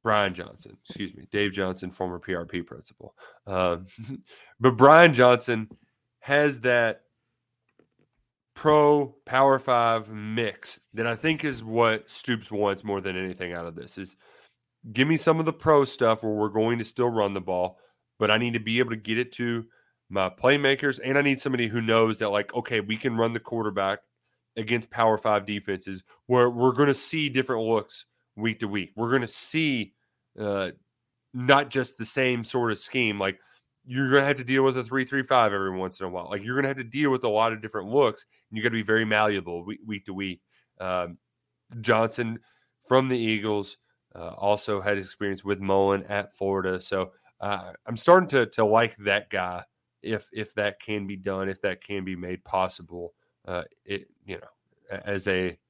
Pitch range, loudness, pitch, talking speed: 100-125 Hz, -25 LUFS, 110 Hz, 190 wpm